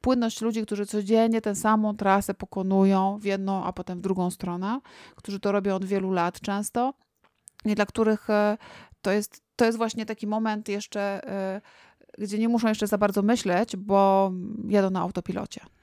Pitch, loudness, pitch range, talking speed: 205 Hz, -26 LUFS, 195-220 Hz, 165 wpm